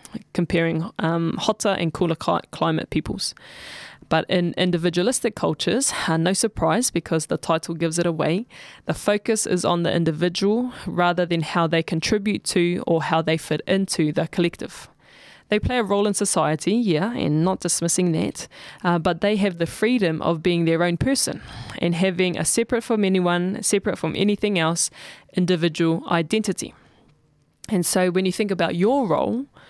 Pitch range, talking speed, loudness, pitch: 165-205 Hz, 160 wpm, -22 LUFS, 175 Hz